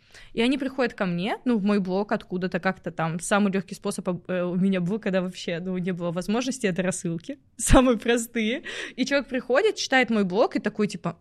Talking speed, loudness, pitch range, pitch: 200 wpm, -25 LUFS, 185-240 Hz, 205 Hz